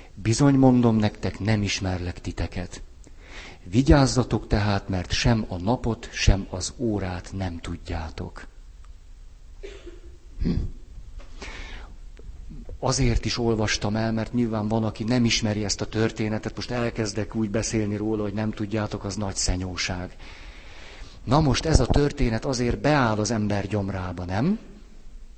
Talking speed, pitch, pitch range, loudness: 125 wpm, 105 Hz, 90-115 Hz, -25 LUFS